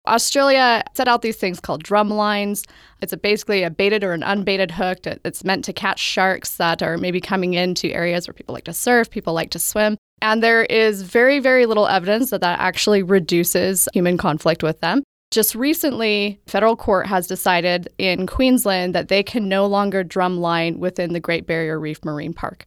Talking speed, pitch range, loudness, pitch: 200 wpm, 175-215 Hz, -19 LUFS, 195 Hz